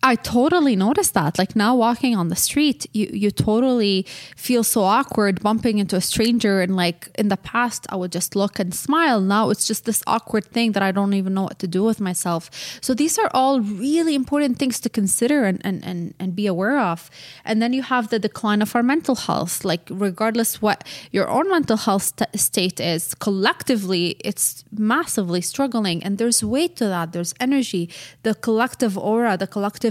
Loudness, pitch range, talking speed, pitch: -20 LUFS, 185-240 Hz, 195 wpm, 210 Hz